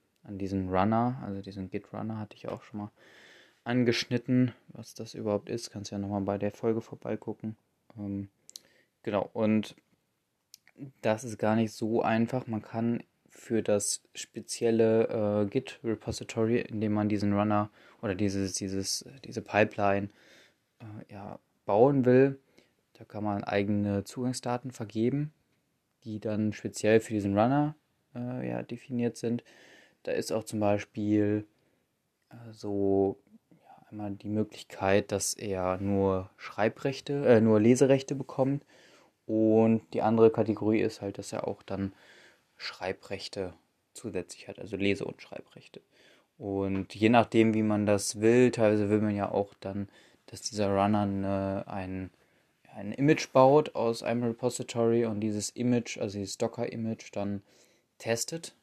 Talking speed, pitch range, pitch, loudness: 140 wpm, 100-115 Hz, 110 Hz, -29 LUFS